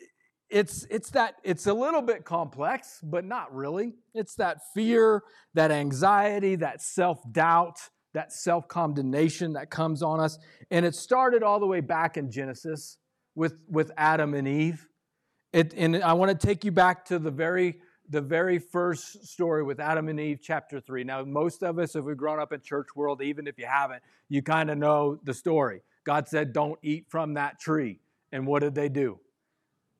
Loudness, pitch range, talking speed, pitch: -27 LUFS, 150-180 Hz, 190 wpm, 160 Hz